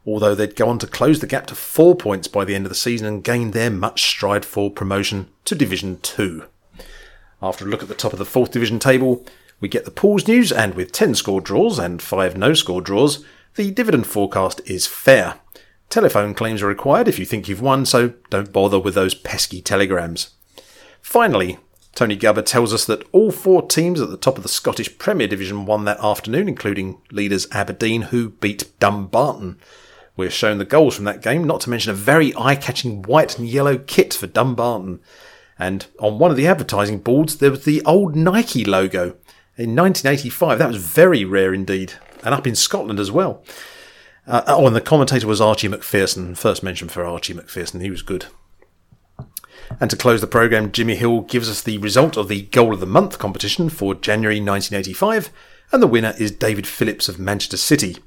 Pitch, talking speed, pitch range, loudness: 110 Hz, 195 wpm, 100-135 Hz, -18 LUFS